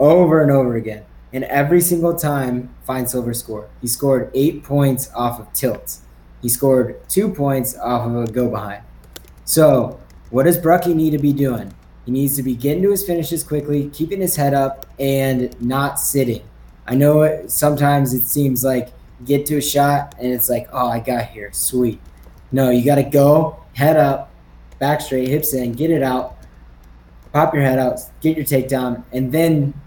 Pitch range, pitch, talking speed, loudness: 120-145 Hz, 135 Hz, 185 wpm, -17 LUFS